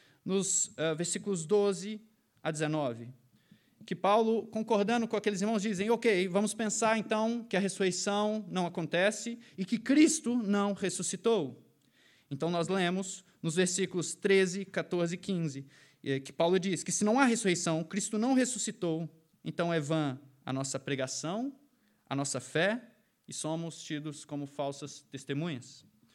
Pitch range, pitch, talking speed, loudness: 160-215 Hz, 190 Hz, 140 wpm, -31 LUFS